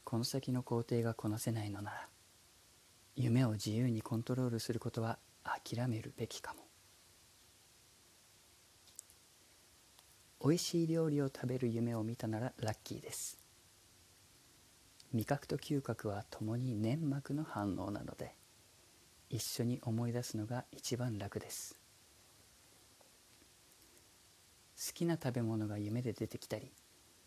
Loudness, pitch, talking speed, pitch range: -39 LUFS, 115 Hz, 230 characters per minute, 105-125 Hz